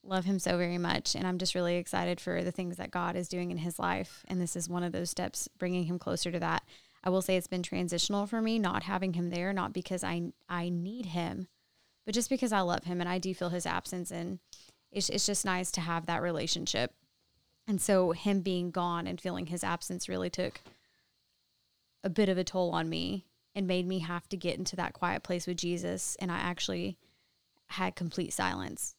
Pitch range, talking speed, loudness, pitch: 175-185 Hz, 220 wpm, -33 LUFS, 180 Hz